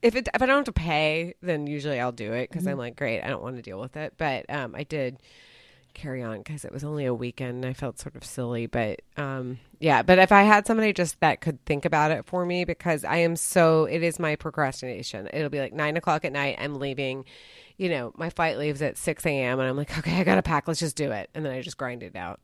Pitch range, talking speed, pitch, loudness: 130-165 Hz, 275 wpm, 150 Hz, -26 LUFS